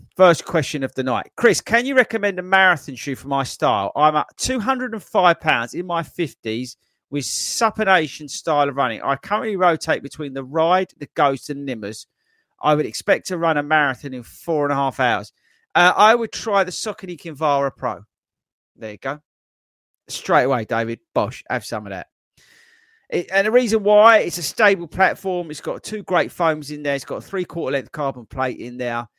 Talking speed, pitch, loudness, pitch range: 195 wpm, 155 Hz, -20 LUFS, 135-195 Hz